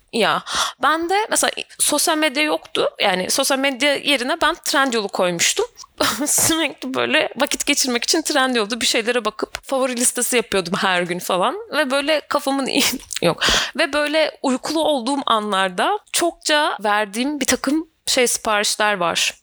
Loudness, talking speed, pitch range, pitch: -18 LUFS, 145 wpm, 240-305 Hz, 275 Hz